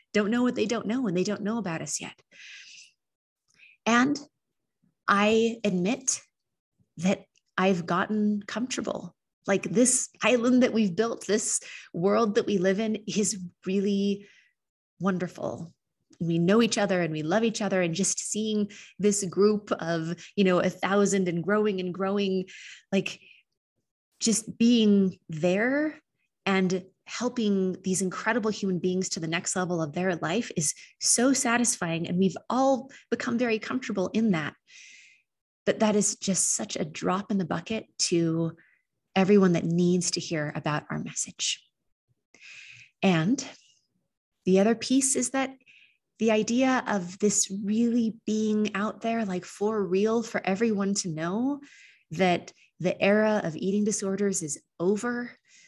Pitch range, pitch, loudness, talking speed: 185-225 Hz, 200 Hz, -26 LUFS, 145 wpm